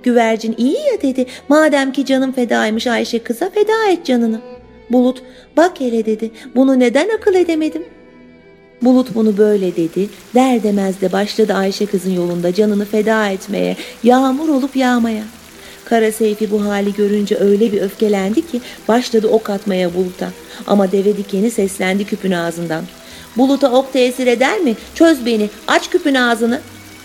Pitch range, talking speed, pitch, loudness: 200-255 Hz, 150 wpm, 225 Hz, -15 LUFS